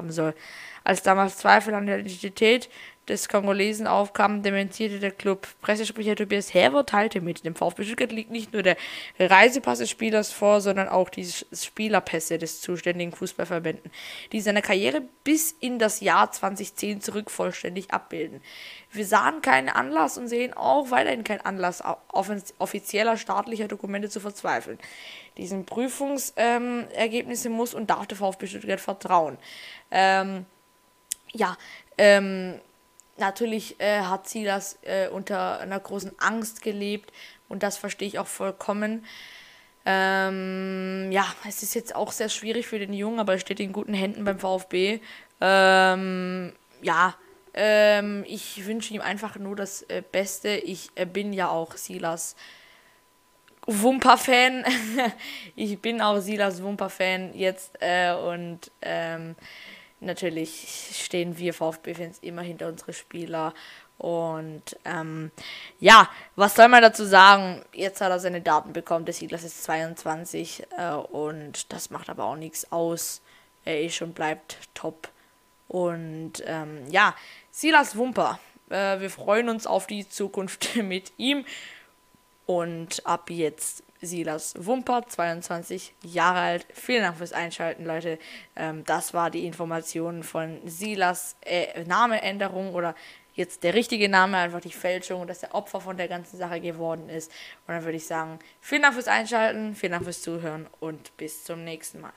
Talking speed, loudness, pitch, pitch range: 145 wpm, -24 LUFS, 190 Hz, 170-210 Hz